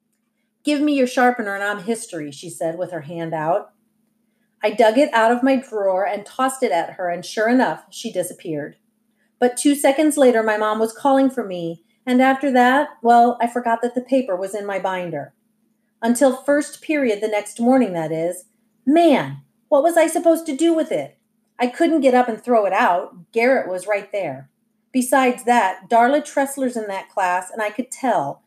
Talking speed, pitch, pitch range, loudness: 195 wpm, 230 Hz, 200-260 Hz, -19 LUFS